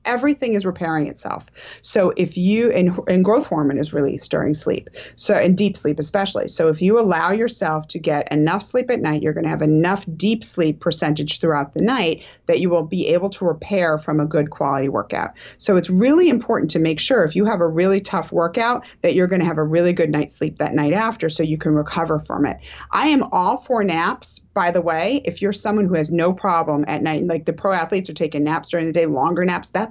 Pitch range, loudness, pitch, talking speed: 155-195 Hz, -19 LUFS, 170 Hz, 235 wpm